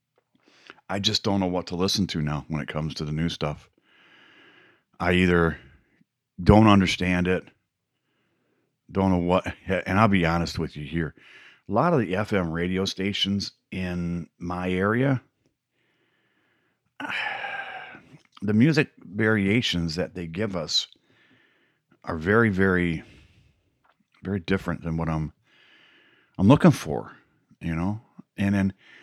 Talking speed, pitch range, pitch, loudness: 130 wpm, 85-100 Hz, 90 Hz, -24 LUFS